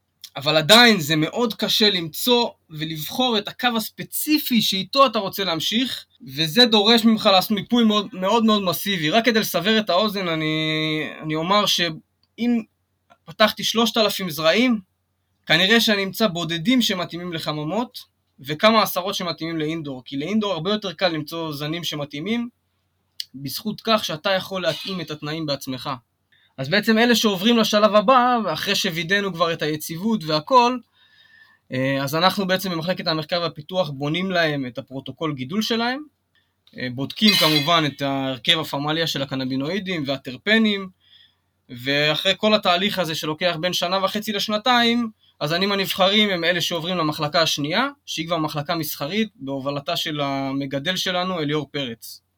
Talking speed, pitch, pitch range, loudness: 135 wpm, 175 Hz, 150-215 Hz, -20 LUFS